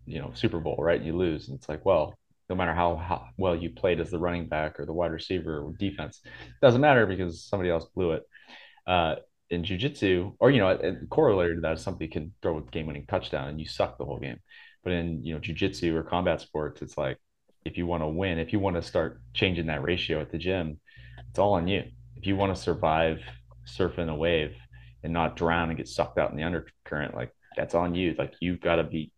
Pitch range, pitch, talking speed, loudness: 75-90 Hz, 85 Hz, 245 wpm, -28 LUFS